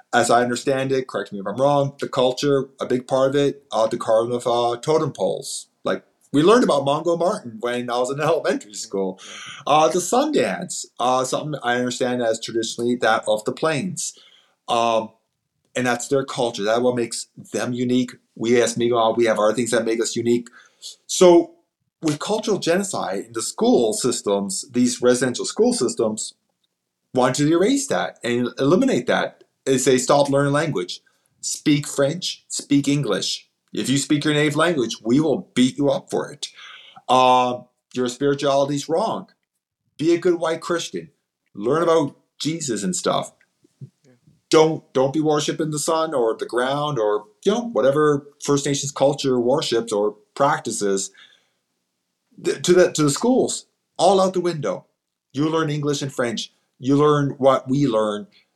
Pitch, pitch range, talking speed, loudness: 135 Hz, 120-150 Hz, 165 wpm, -21 LUFS